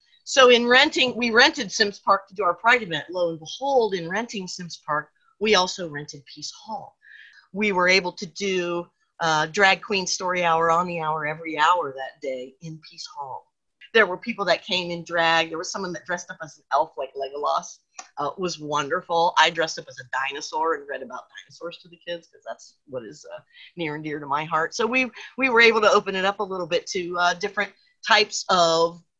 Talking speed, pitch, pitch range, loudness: 220 wpm, 180 Hz, 165-215 Hz, -22 LUFS